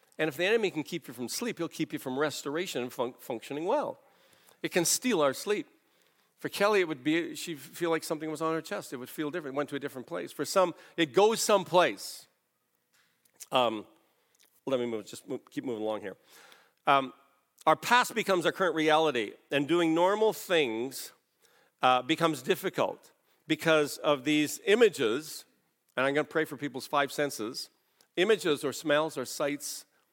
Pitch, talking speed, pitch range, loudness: 155 Hz, 185 wpm, 140-180 Hz, -29 LUFS